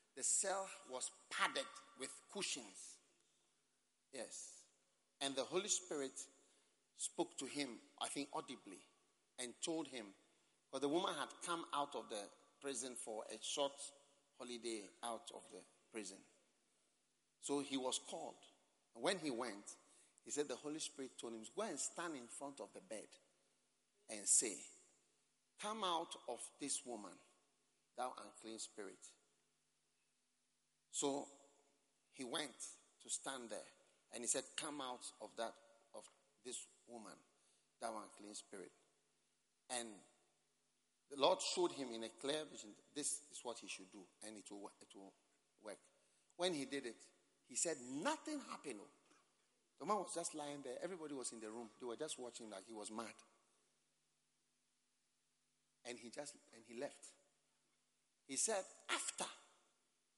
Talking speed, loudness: 150 wpm, -45 LUFS